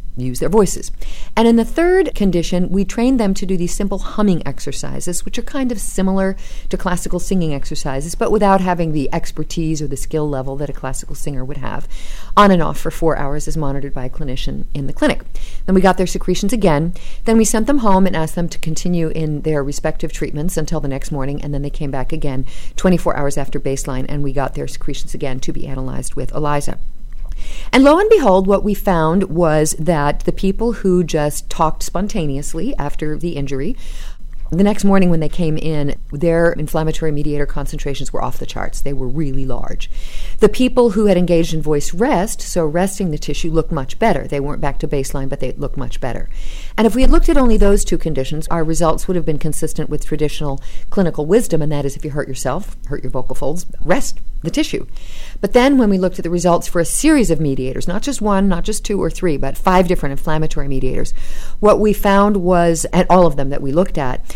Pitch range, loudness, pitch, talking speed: 145-190 Hz, -18 LUFS, 160 Hz, 220 wpm